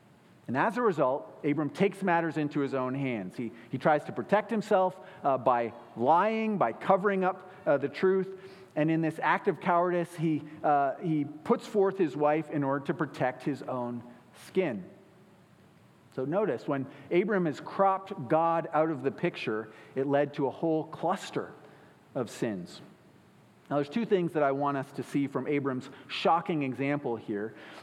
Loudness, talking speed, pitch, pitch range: -30 LUFS, 175 wpm, 155 Hz, 140-185 Hz